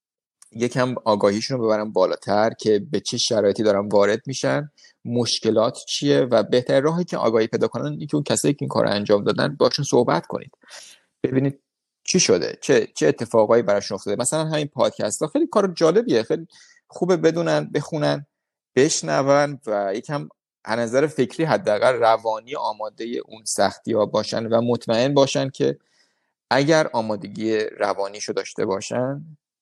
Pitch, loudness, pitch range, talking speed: 130 Hz, -21 LUFS, 110-150 Hz, 150 wpm